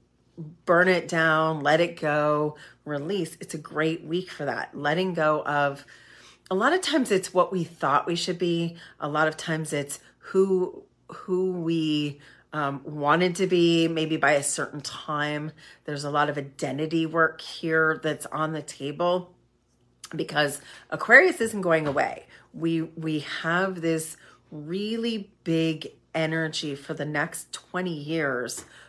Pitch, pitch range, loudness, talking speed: 160 Hz, 150-175 Hz, -25 LUFS, 150 wpm